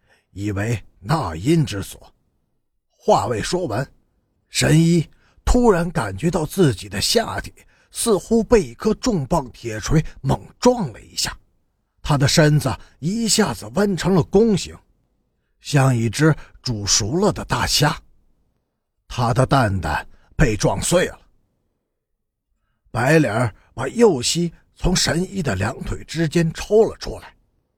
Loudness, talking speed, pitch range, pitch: -20 LUFS, 180 characters per minute, 105-175 Hz, 145 Hz